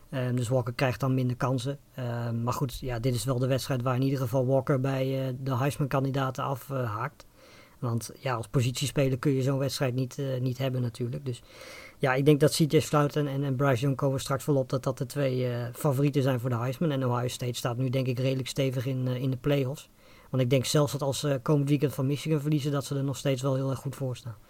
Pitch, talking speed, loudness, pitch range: 135 Hz, 245 wpm, -28 LUFS, 130-140 Hz